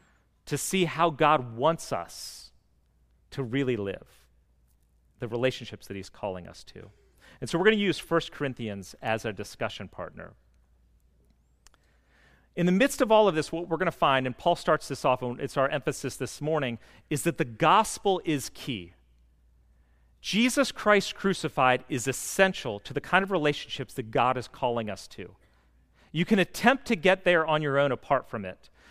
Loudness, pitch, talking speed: -27 LUFS, 135 Hz, 175 wpm